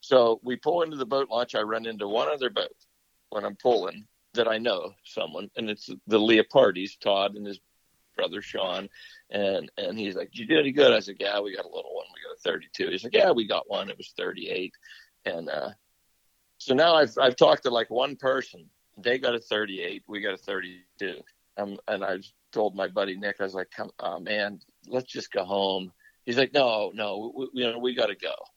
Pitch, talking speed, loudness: 120 Hz, 220 wpm, -27 LUFS